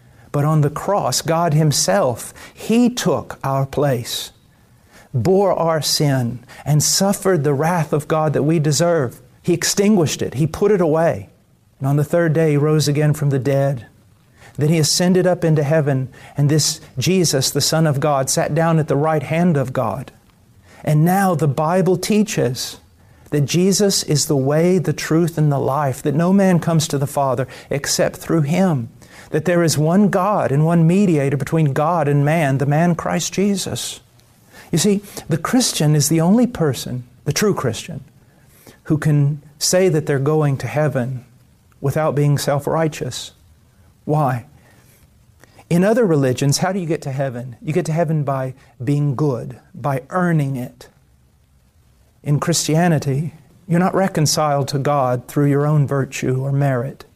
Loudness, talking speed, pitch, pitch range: -18 LUFS, 165 wpm, 150 Hz, 135-165 Hz